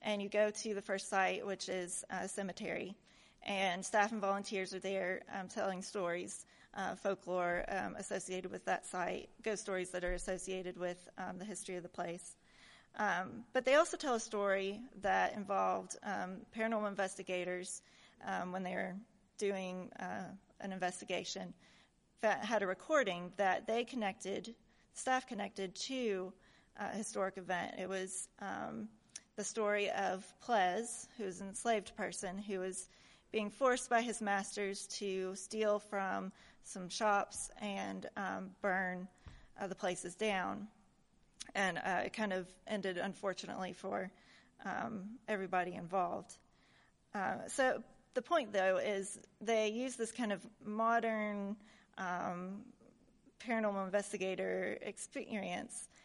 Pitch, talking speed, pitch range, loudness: 195 Hz, 140 wpm, 185-215 Hz, -39 LUFS